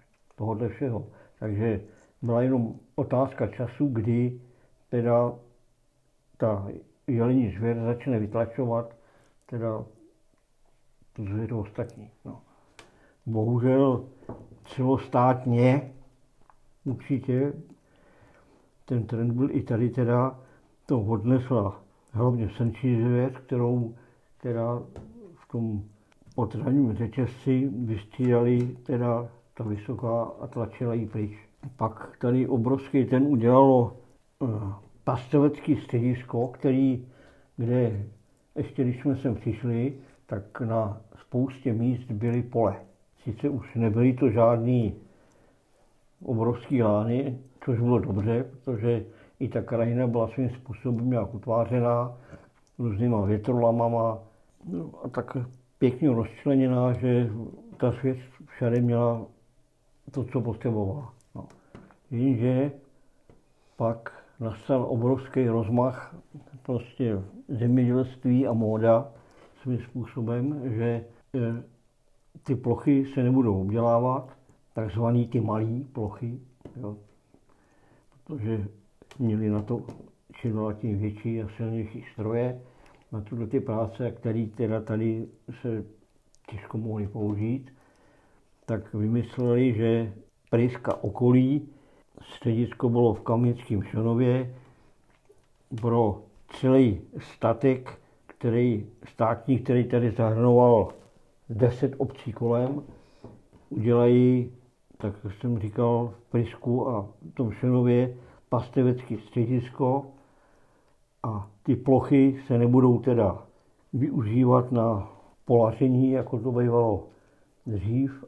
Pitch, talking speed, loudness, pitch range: 120 Hz, 95 wpm, -26 LUFS, 115-130 Hz